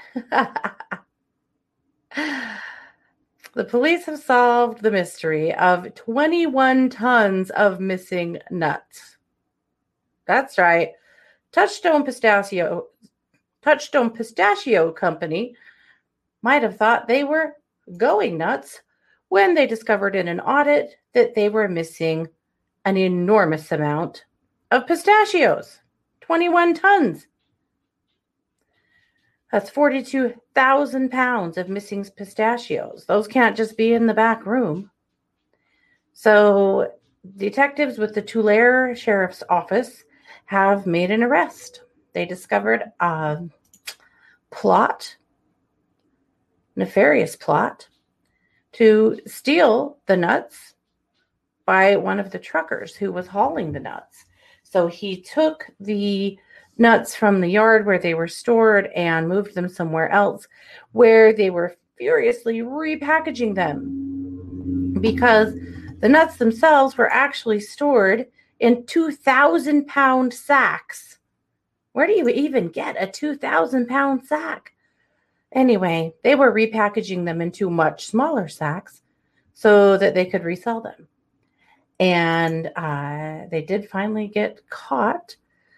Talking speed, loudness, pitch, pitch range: 105 wpm, -19 LUFS, 215 Hz, 180-265 Hz